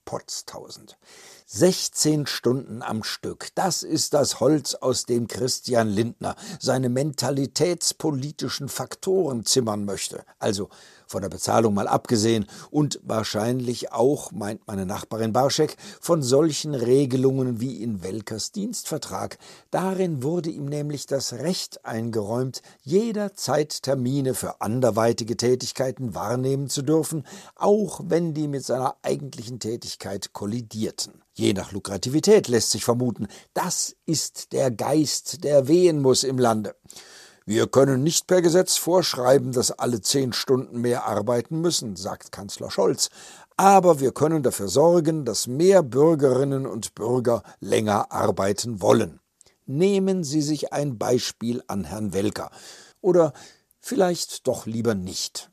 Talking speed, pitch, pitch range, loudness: 130 wpm, 130 Hz, 115-155 Hz, -23 LUFS